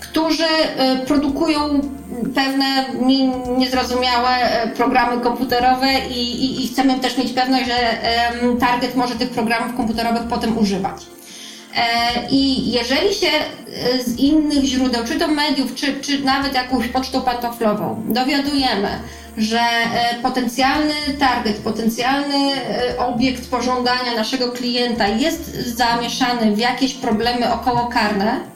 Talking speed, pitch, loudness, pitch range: 105 wpm, 250 Hz, -18 LUFS, 235-270 Hz